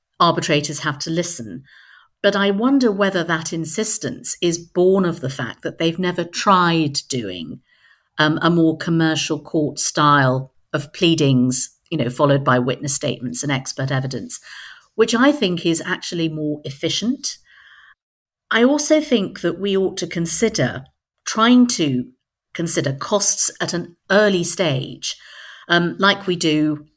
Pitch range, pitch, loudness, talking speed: 145-185 Hz, 165 Hz, -19 LUFS, 140 wpm